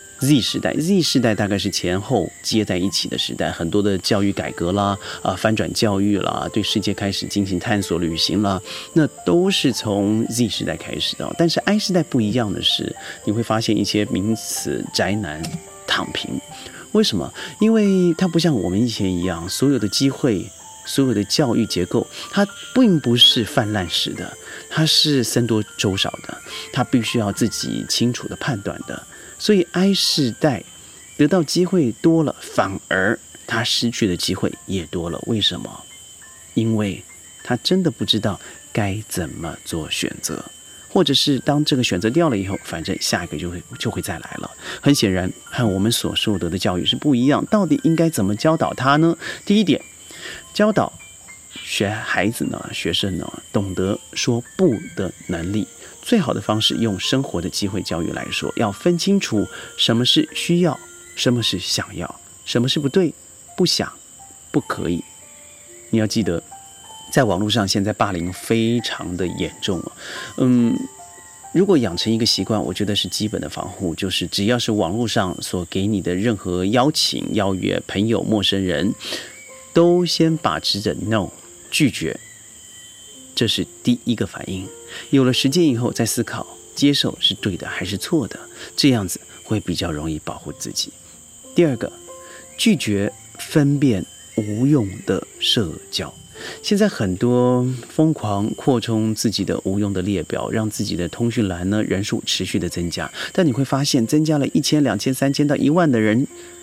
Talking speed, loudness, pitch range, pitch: 250 characters per minute, -20 LUFS, 100-145 Hz, 115 Hz